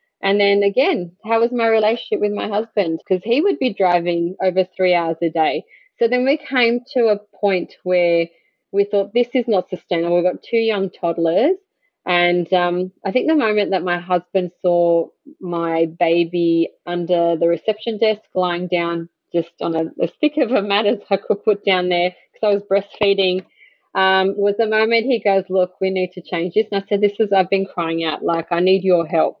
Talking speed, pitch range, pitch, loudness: 205 wpm, 175-215 Hz, 190 Hz, -18 LUFS